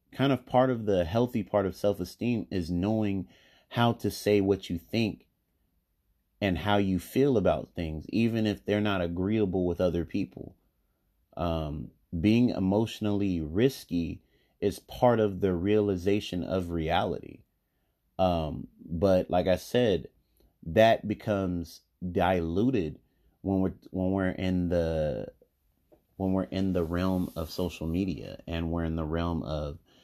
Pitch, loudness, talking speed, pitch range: 95 Hz, -29 LUFS, 140 wpm, 85-105 Hz